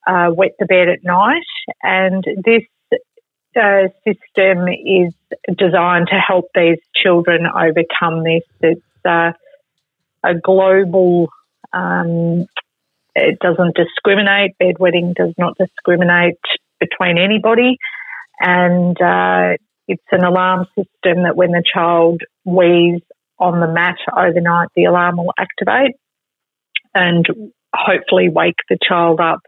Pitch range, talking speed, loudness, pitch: 170-190 Hz, 115 wpm, -14 LUFS, 180 Hz